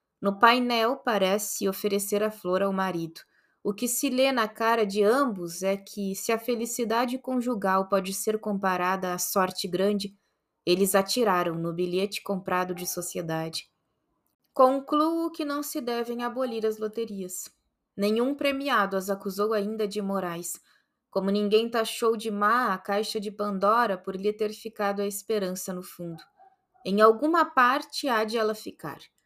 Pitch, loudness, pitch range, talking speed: 210 Hz, -27 LUFS, 195-235 Hz, 150 wpm